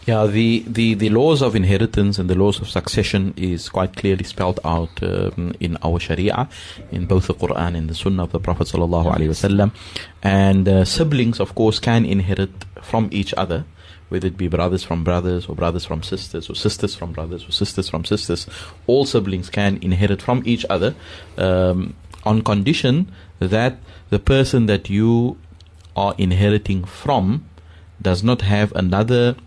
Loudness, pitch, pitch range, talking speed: -19 LUFS, 95 Hz, 90-105 Hz, 165 wpm